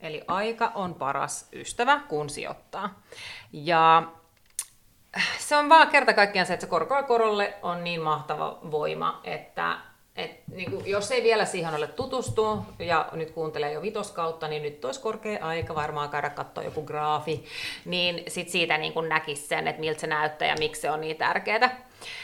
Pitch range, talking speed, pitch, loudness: 155-225 Hz, 175 wpm, 170 Hz, -26 LUFS